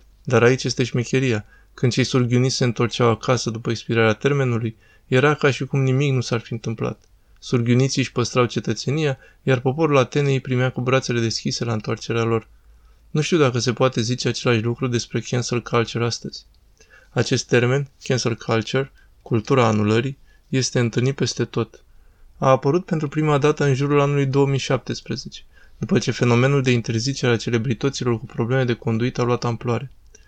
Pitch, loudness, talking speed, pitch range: 125 Hz, -21 LUFS, 165 wpm, 115-135 Hz